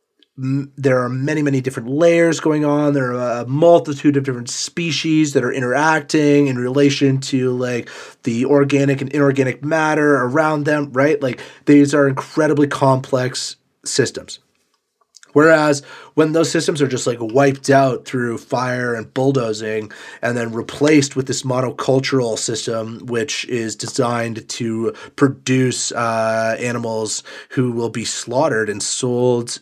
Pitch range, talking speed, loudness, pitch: 120-145 Hz, 140 wpm, -17 LUFS, 135 Hz